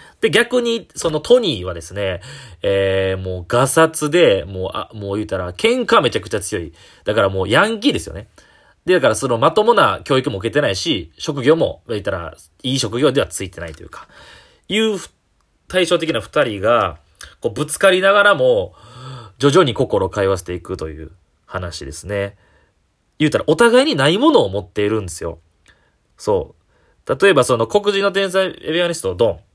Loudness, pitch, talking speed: -17 LUFS, 120 Hz, 345 characters per minute